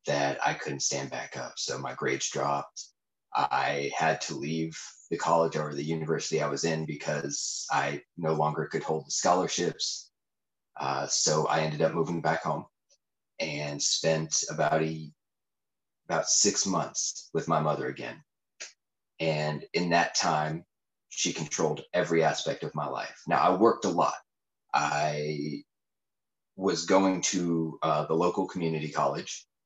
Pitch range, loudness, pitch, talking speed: 75-80 Hz, -29 LUFS, 80 Hz, 150 wpm